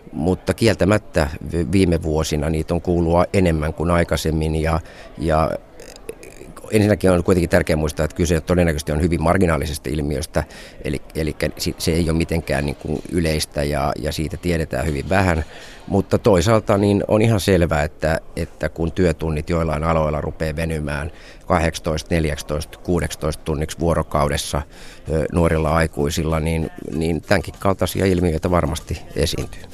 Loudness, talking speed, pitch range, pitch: -20 LUFS, 135 wpm, 75-90 Hz, 80 Hz